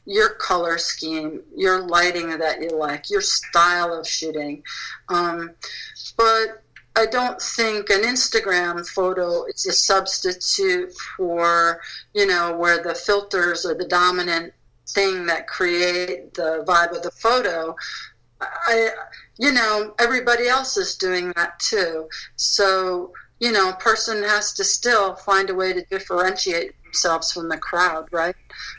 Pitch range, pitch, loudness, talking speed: 170-220 Hz, 185 Hz, -20 LUFS, 140 wpm